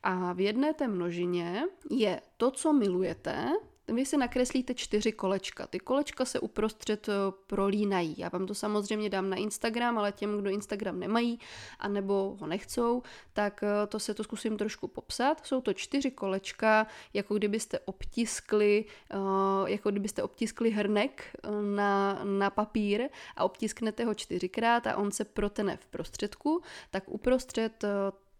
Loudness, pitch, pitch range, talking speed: -31 LUFS, 210 Hz, 195-235 Hz, 140 wpm